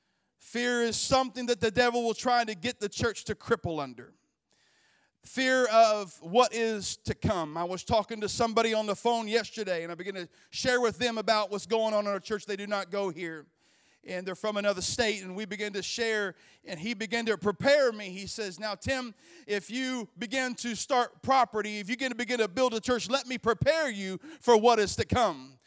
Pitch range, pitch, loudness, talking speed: 200-245 Hz, 225 Hz, -29 LUFS, 215 wpm